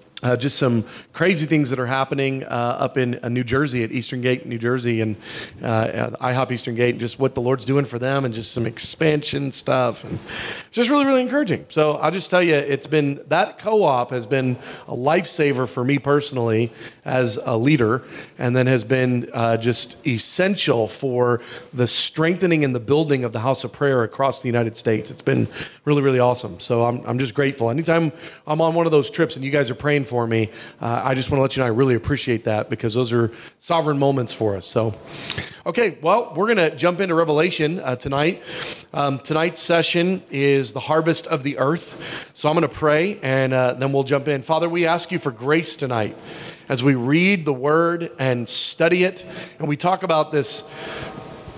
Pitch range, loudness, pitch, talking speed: 125-155 Hz, -20 LUFS, 135 Hz, 210 wpm